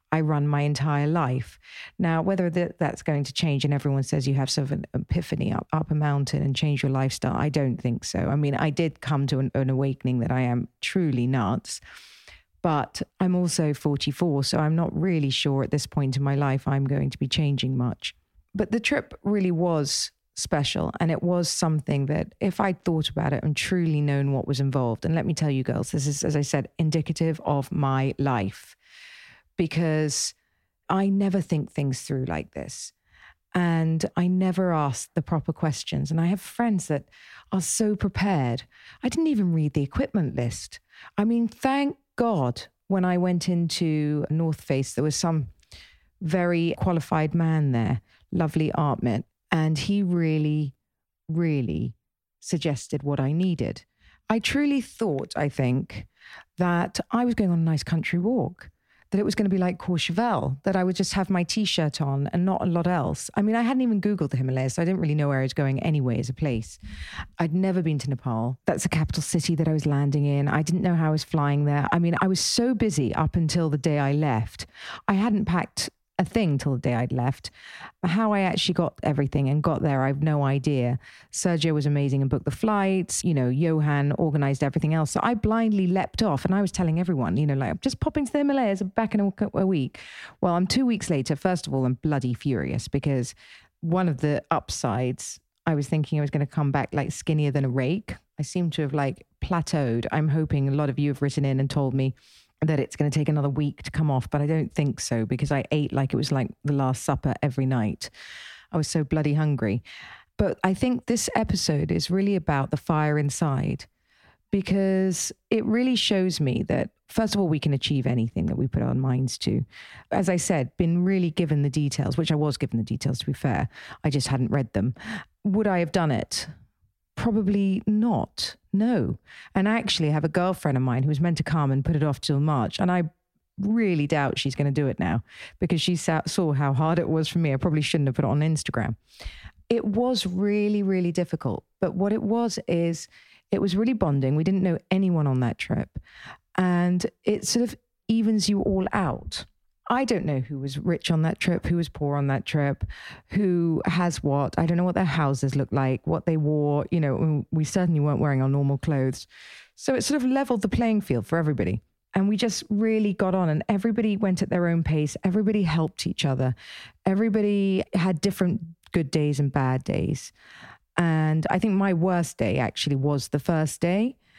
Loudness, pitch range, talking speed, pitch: -25 LUFS, 140-185 Hz, 210 wpm, 155 Hz